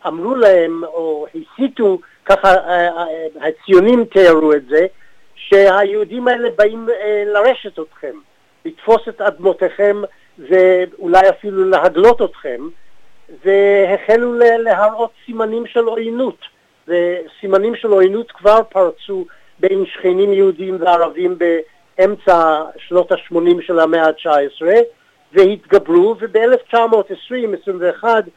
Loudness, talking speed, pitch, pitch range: -14 LUFS, 90 wpm, 195 Hz, 175-230 Hz